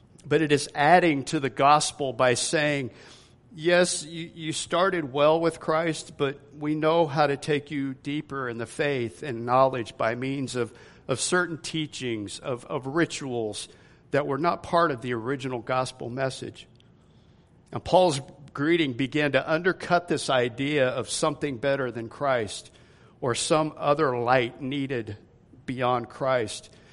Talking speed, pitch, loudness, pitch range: 145 wpm, 140 Hz, -26 LUFS, 125-155 Hz